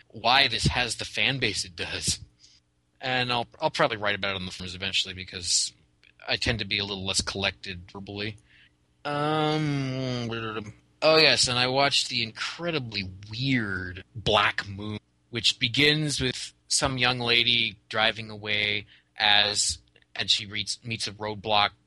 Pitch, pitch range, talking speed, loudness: 105 Hz, 100-125 Hz, 150 wpm, -25 LUFS